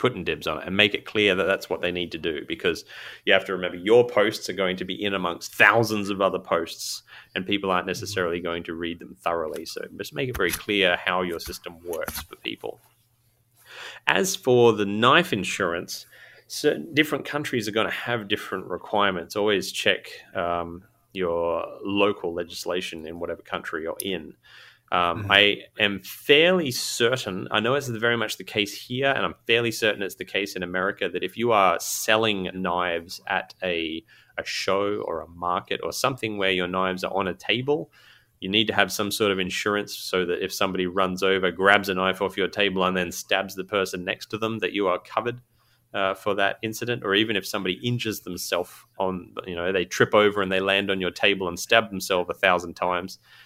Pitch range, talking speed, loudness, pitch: 90-110 Hz, 205 wpm, -24 LUFS, 100 Hz